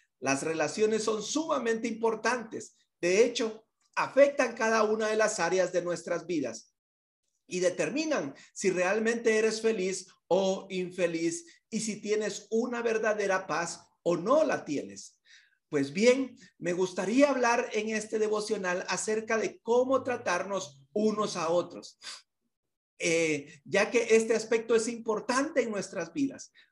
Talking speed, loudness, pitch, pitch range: 130 wpm, -29 LUFS, 215 Hz, 180-235 Hz